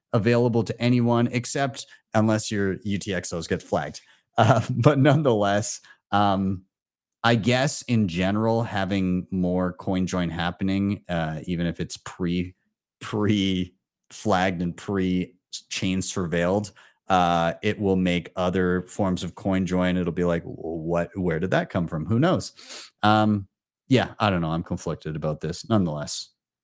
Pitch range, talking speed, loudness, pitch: 90-110 Hz, 140 wpm, -24 LUFS, 95 Hz